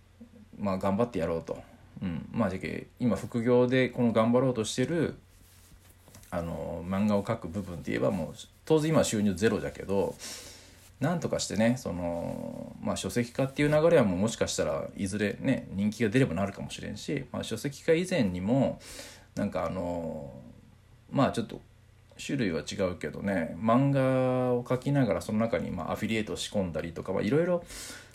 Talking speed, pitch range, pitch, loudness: 330 characters per minute, 95-125 Hz, 105 Hz, -29 LUFS